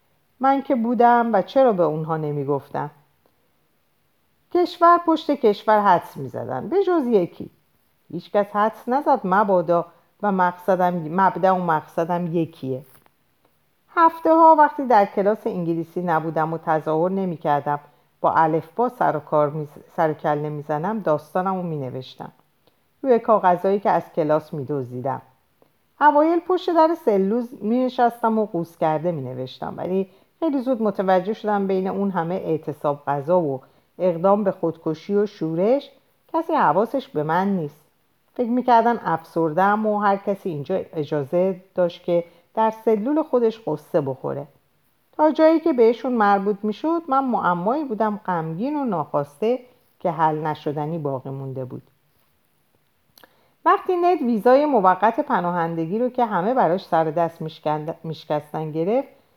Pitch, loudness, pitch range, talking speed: 185 Hz, -21 LUFS, 160-235 Hz, 140 wpm